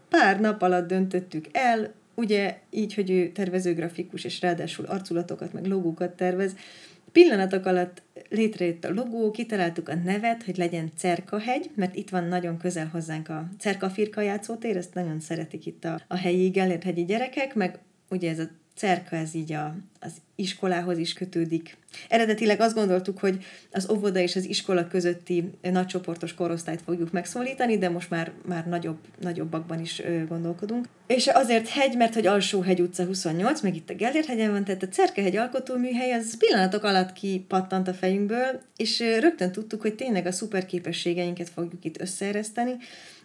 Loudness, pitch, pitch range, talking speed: -27 LUFS, 185 Hz, 175-210 Hz, 160 wpm